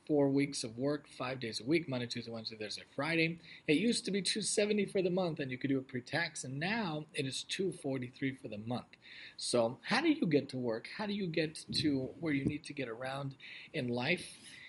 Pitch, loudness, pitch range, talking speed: 140 Hz, -36 LUFS, 125-170 Hz, 235 wpm